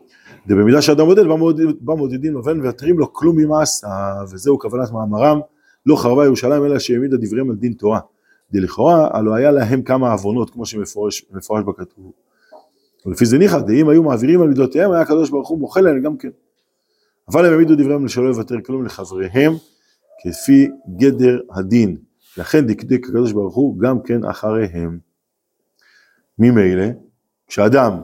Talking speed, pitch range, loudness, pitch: 150 wpm, 110-150 Hz, -15 LUFS, 125 Hz